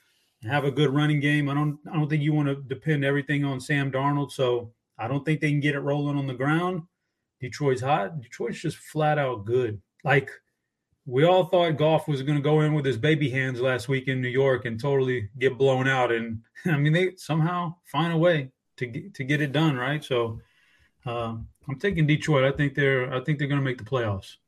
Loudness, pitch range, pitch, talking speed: -25 LUFS, 130-150 Hz, 140 Hz, 225 wpm